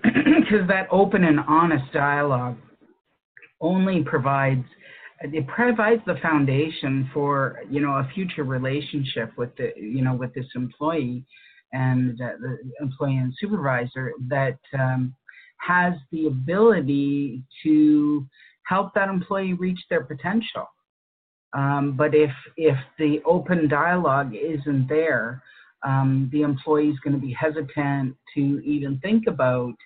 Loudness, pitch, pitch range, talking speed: -23 LUFS, 145 Hz, 135-165 Hz, 130 wpm